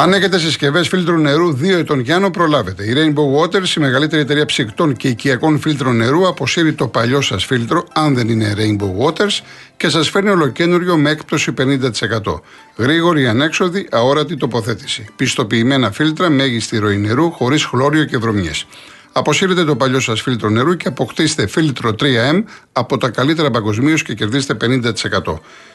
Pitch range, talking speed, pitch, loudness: 120-160 Hz, 155 wpm, 145 Hz, -15 LUFS